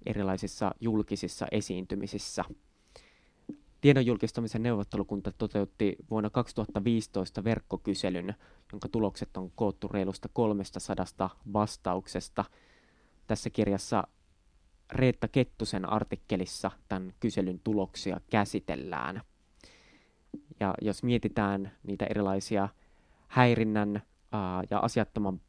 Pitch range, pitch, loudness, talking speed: 95-110 Hz, 100 Hz, -32 LUFS, 80 wpm